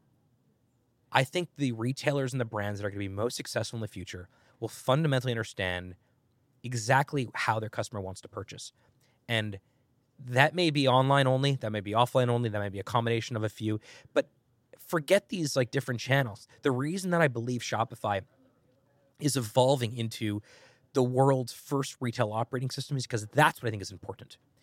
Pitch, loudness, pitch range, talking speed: 125 Hz, -29 LUFS, 110-135 Hz, 185 wpm